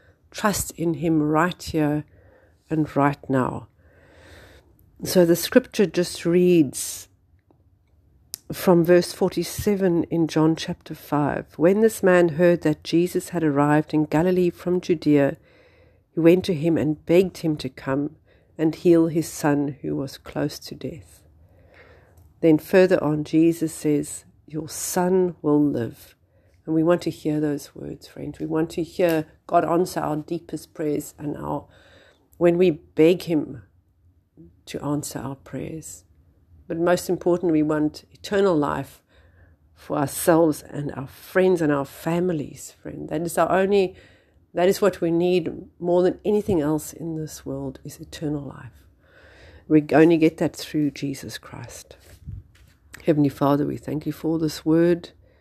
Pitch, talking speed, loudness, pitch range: 155 Hz, 145 wpm, -22 LUFS, 130-170 Hz